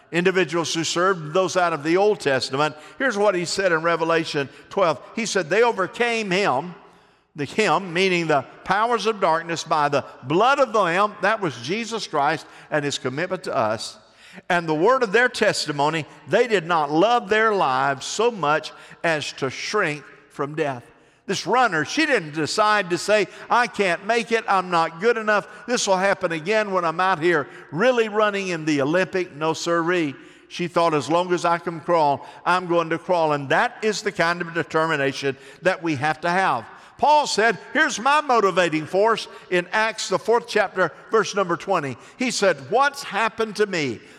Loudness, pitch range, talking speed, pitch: -21 LUFS, 160-210 Hz, 185 wpm, 180 Hz